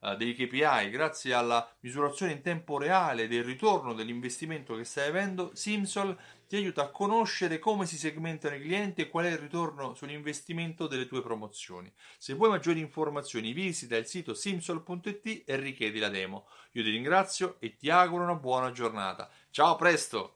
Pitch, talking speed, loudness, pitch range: 155 Hz, 170 wpm, -31 LUFS, 125-180 Hz